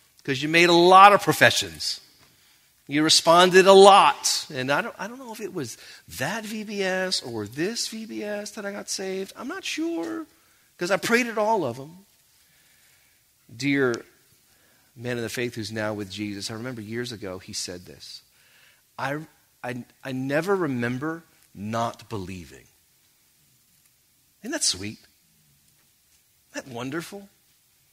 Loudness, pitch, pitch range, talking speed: -22 LUFS, 140 Hz, 115-195 Hz, 145 wpm